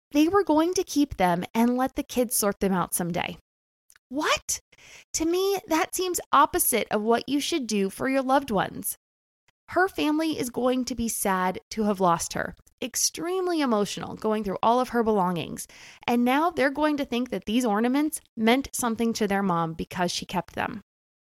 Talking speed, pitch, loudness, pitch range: 185 wpm, 240 Hz, -25 LUFS, 200-295 Hz